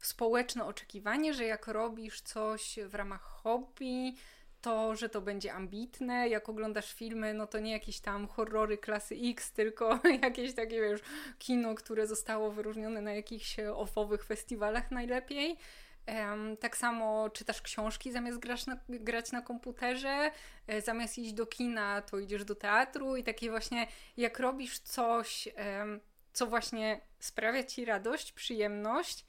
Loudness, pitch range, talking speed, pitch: -36 LUFS, 215-245 Hz, 135 wpm, 225 Hz